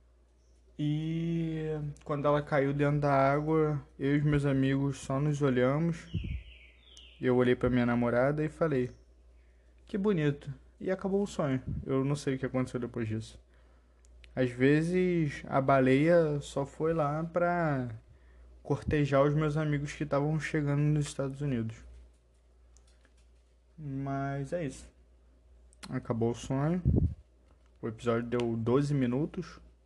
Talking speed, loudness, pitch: 130 wpm, -31 LUFS, 135 Hz